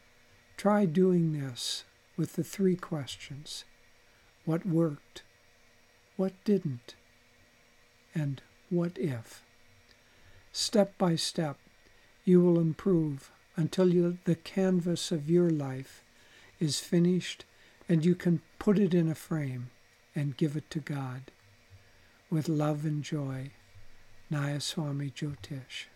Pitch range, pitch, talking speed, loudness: 120-170 Hz, 145 Hz, 110 wpm, -30 LUFS